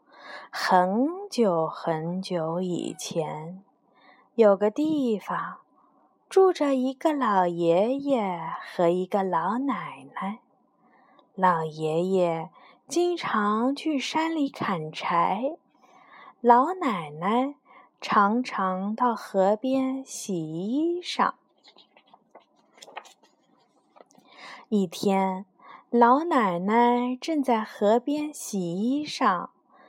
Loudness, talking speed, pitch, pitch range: -25 LUFS, 110 characters per minute, 235 Hz, 185-270 Hz